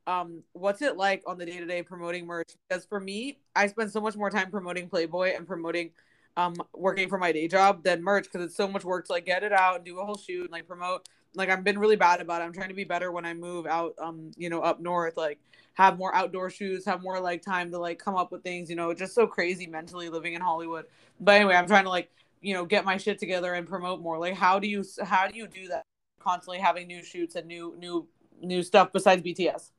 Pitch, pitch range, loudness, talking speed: 180 Hz, 170-190 Hz, -28 LUFS, 260 wpm